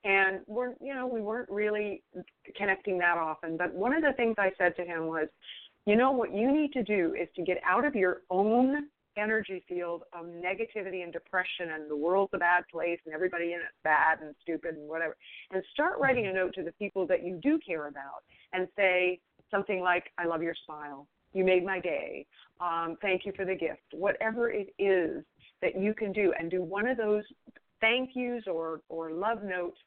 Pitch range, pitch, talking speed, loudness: 170-220 Hz, 190 Hz, 210 wpm, -30 LUFS